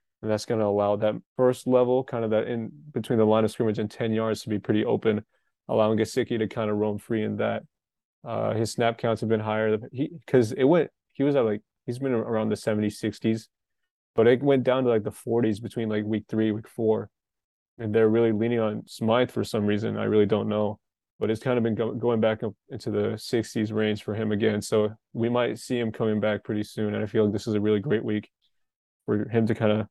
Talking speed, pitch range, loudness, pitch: 240 wpm, 105-115 Hz, -26 LUFS, 110 Hz